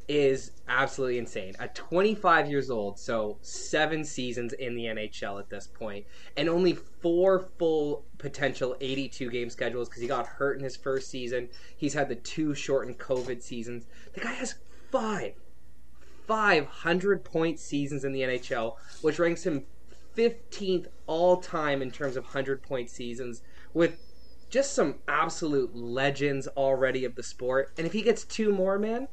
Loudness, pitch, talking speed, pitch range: -29 LUFS, 140 Hz, 160 wpm, 125-165 Hz